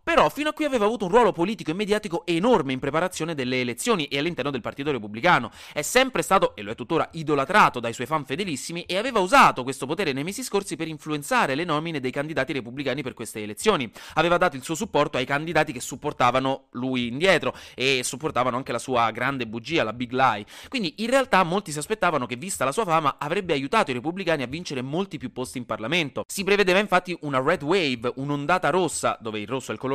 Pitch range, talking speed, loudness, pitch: 130-180 Hz, 215 wpm, -24 LUFS, 150 Hz